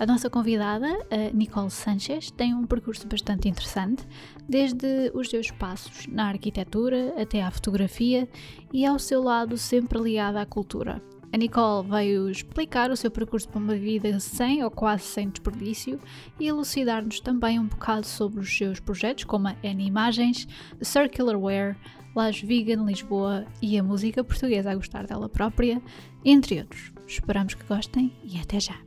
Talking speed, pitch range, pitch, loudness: 160 wpm, 200-245 Hz, 220 Hz, -26 LUFS